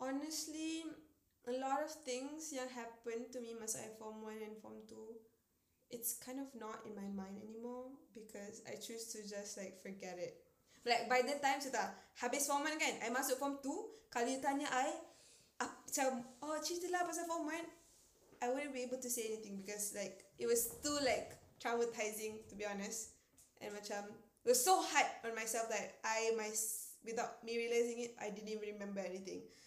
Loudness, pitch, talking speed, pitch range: -41 LUFS, 235 Hz, 185 wpm, 220-280 Hz